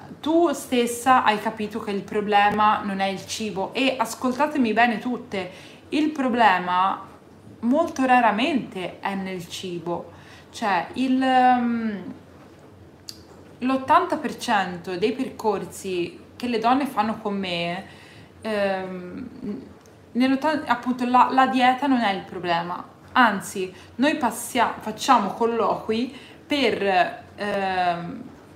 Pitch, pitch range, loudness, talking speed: 225 Hz, 195-255 Hz, -23 LUFS, 105 wpm